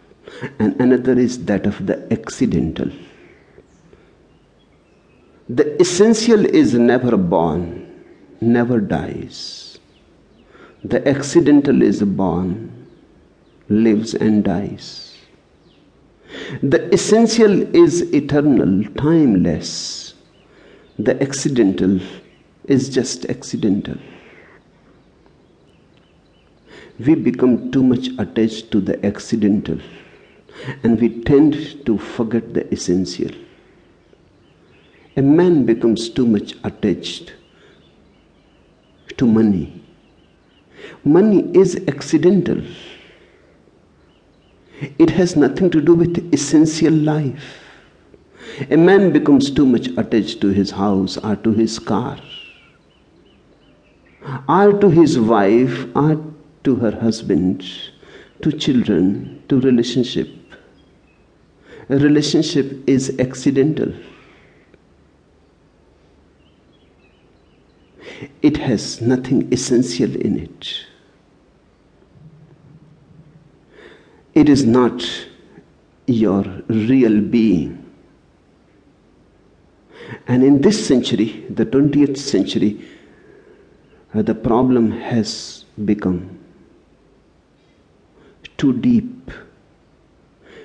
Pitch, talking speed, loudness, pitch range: 125 Hz, 80 wpm, -16 LUFS, 105-150 Hz